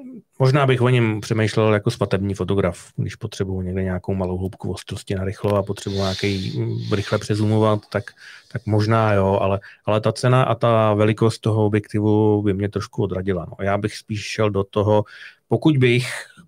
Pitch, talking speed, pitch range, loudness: 105 Hz, 175 wpm, 100-115 Hz, -21 LUFS